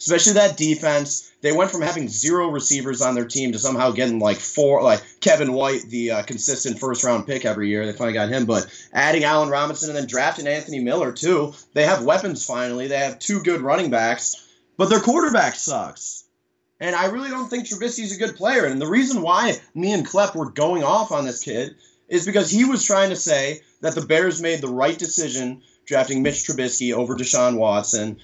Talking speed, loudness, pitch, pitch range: 210 wpm, -20 LUFS, 140 Hz, 125-170 Hz